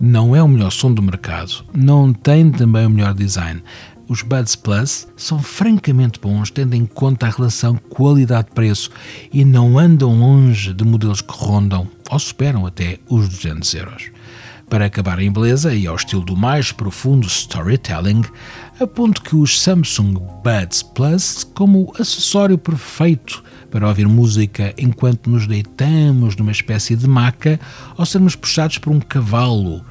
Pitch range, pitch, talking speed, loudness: 105-140 Hz, 115 Hz, 155 wpm, -15 LUFS